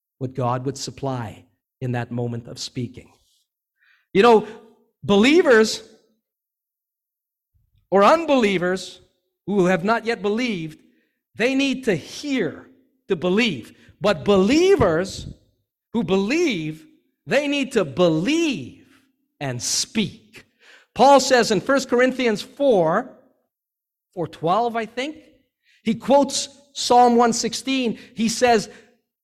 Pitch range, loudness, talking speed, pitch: 185-265 Hz, -20 LUFS, 105 wpm, 225 Hz